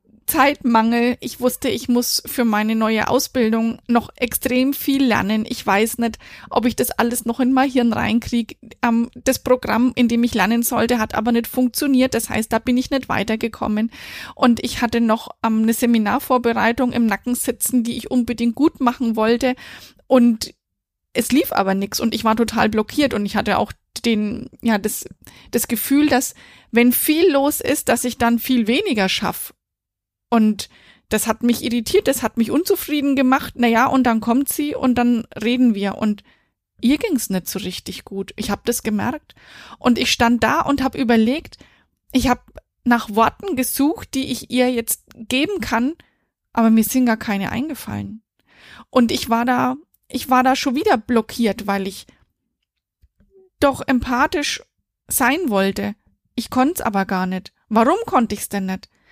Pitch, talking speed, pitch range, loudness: 240 Hz, 175 wpm, 225-260 Hz, -19 LUFS